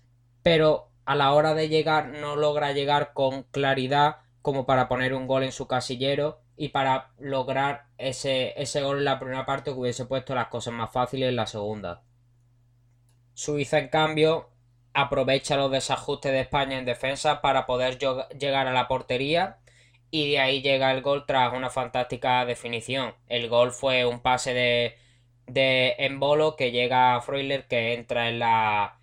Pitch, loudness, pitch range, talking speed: 130 Hz, -25 LUFS, 120-140 Hz, 170 wpm